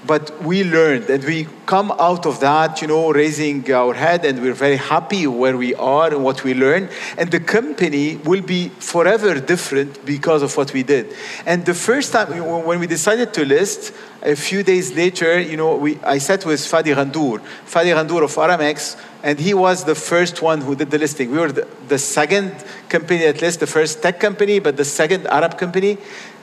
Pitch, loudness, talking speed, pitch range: 160 Hz, -17 LUFS, 205 wpm, 145-180 Hz